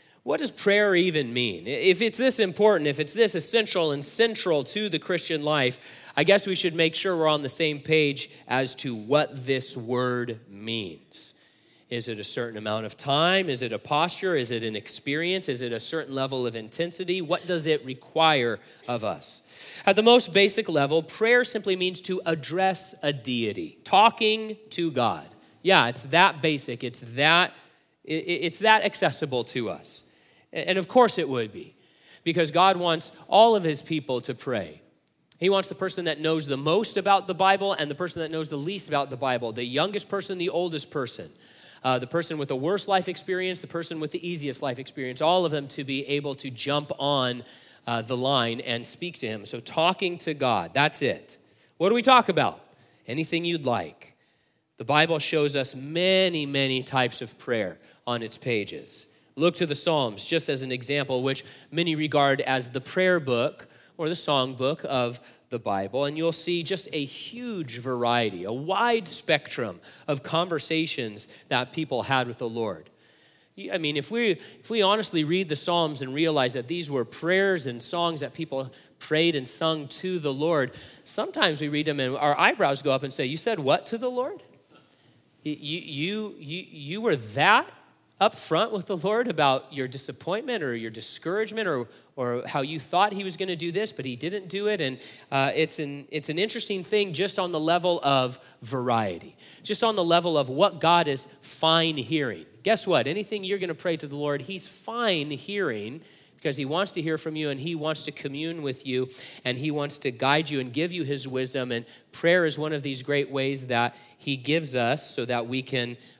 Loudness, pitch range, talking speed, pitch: -25 LUFS, 130-180 Hz, 200 wpm, 155 Hz